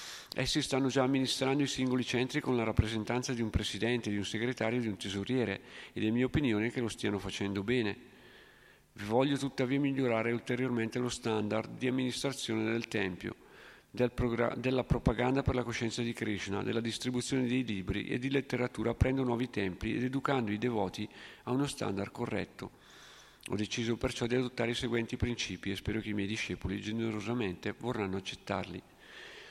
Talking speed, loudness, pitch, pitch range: 170 wpm, -34 LUFS, 120 Hz, 105-130 Hz